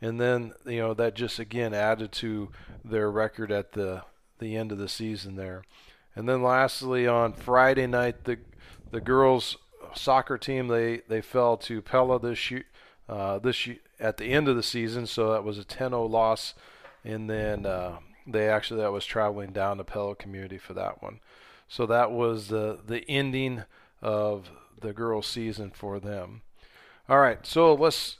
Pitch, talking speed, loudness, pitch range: 110 Hz, 175 wpm, -27 LUFS, 105-120 Hz